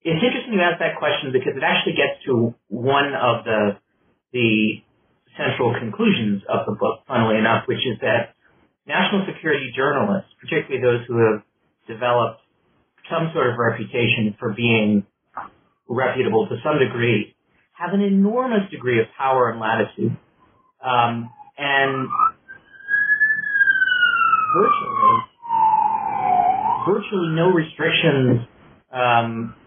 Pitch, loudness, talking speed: 140 Hz, -20 LUFS, 115 wpm